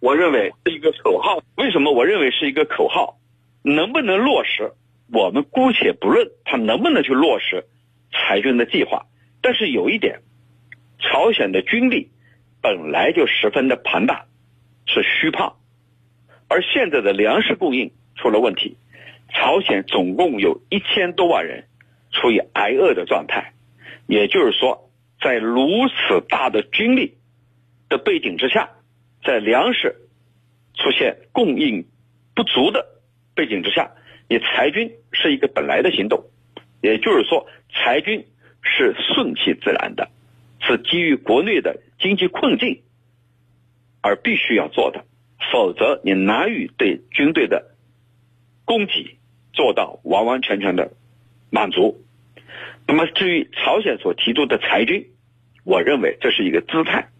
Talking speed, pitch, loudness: 210 characters per minute, 120 Hz, -18 LUFS